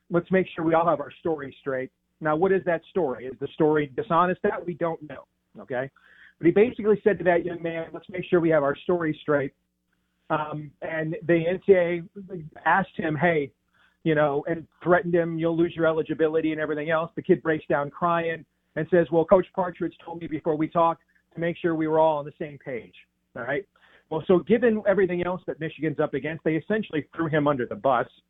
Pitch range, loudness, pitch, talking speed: 150-175 Hz, -25 LUFS, 165 Hz, 215 wpm